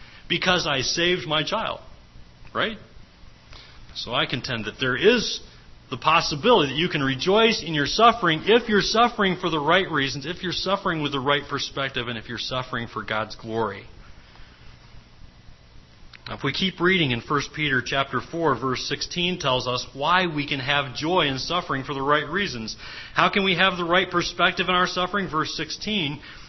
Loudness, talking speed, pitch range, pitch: -23 LUFS, 180 wpm, 125-180 Hz, 150 Hz